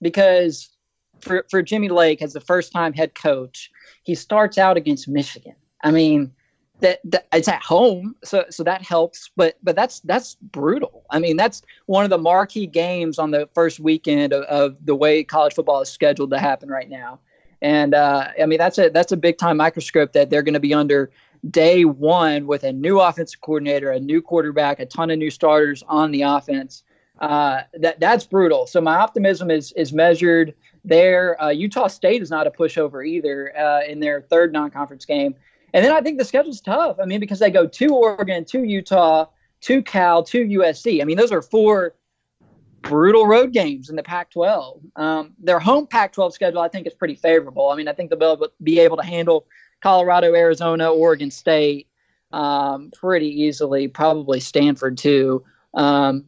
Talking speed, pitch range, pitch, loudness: 190 wpm, 150-185 Hz, 165 Hz, -18 LUFS